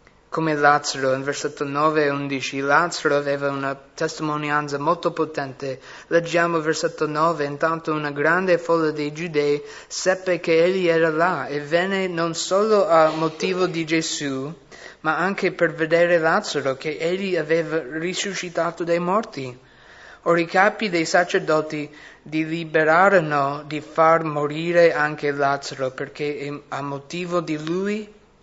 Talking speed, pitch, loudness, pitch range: 135 wpm, 160 Hz, -21 LUFS, 145-170 Hz